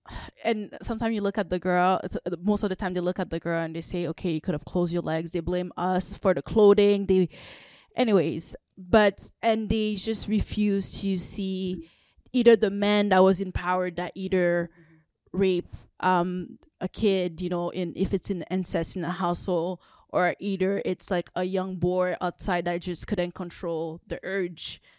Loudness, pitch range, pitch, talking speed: -26 LUFS, 175-200 Hz, 185 Hz, 190 wpm